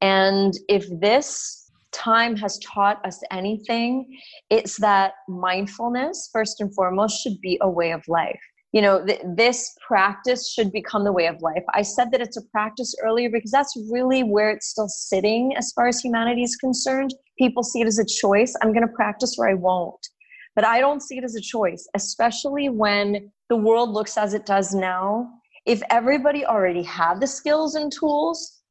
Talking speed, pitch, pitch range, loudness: 185 wpm, 225 Hz, 200-250 Hz, -22 LUFS